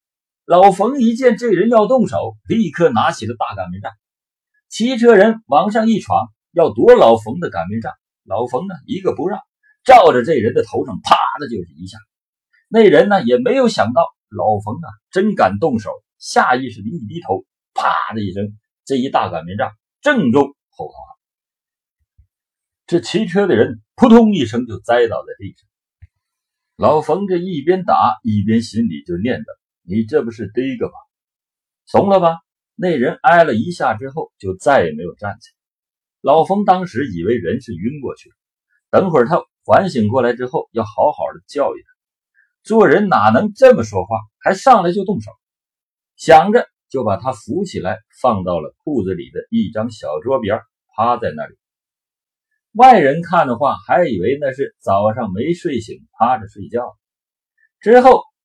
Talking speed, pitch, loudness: 240 characters per minute, 180 Hz, -15 LUFS